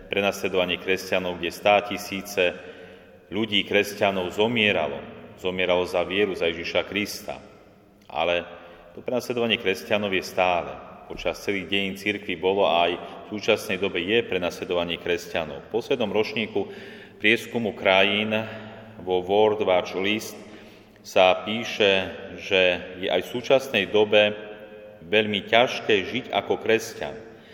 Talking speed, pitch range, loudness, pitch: 120 wpm, 90-105 Hz, -24 LUFS, 100 Hz